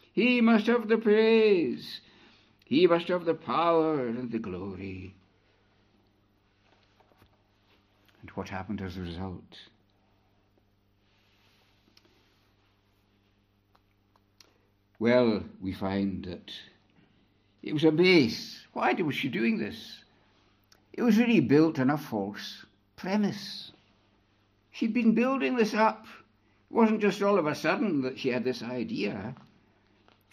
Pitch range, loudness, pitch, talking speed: 100-150 Hz, -27 LUFS, 100 Hz, 115 wpm